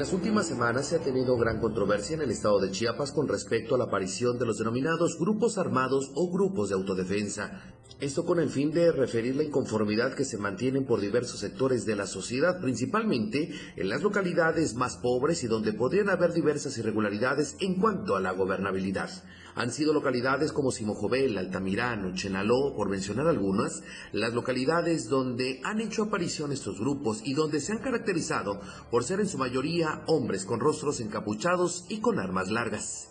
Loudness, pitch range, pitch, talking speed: -28 LUFS, 110-165 Hz, 130 Hz, 180 wpm